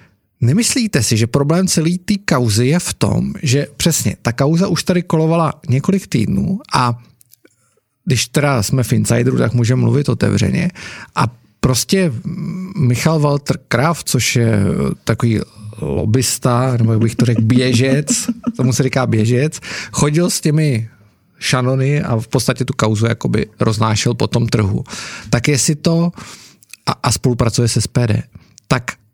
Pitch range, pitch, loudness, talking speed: 120-165 Hz, 130 Hz, -16 LUFS, 150 wpm